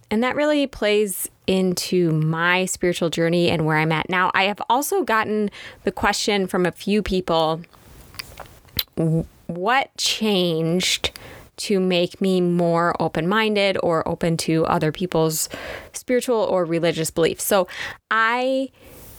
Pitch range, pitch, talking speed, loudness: 165-210 Hz, 180 Hz, 130 wpm, -21 LUFS